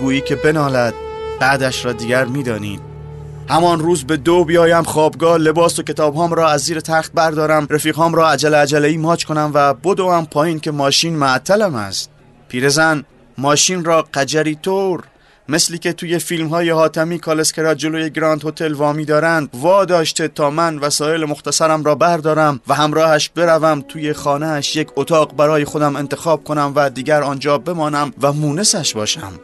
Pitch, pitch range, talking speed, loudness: 155 Hz, 145-165 Hz, 165 wpm, -15 LUFS